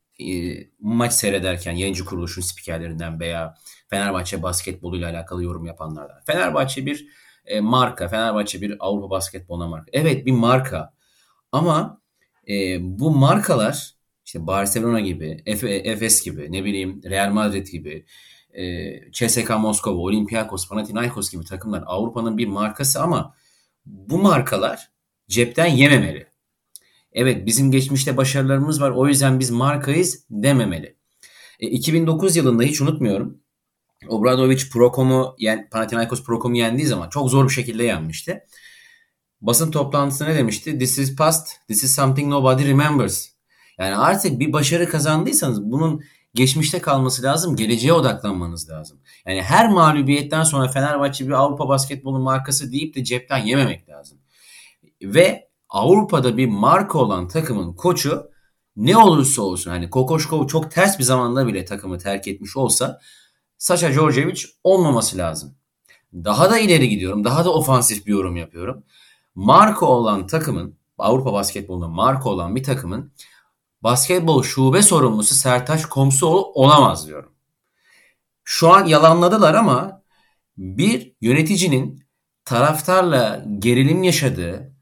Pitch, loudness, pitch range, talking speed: 125 Hz, -18 LUFS, 100-145 Hz, 125 wpm